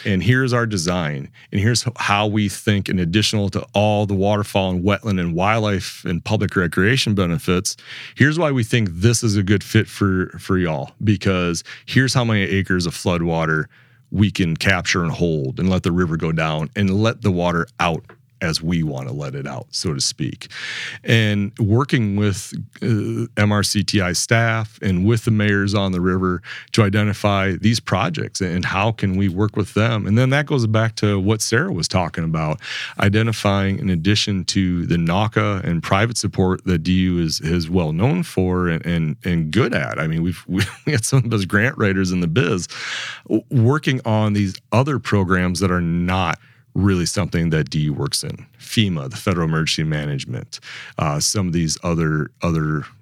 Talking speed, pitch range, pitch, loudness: 185 wpm, 90-110 Hz, 100 Hz, -19 LUFS